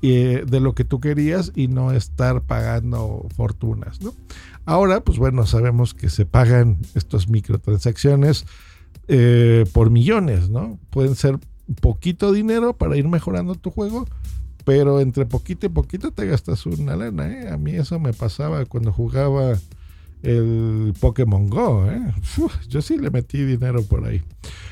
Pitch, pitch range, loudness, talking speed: 120 Hz, 110-140 Hz, -19 LUFS, 150 wpm